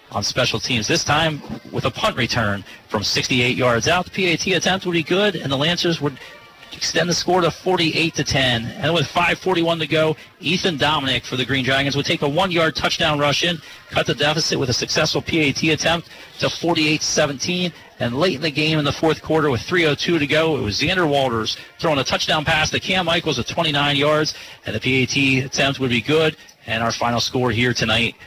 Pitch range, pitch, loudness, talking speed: 130-165 Hz, 150 Hz, -19 LUFS, 205 wpm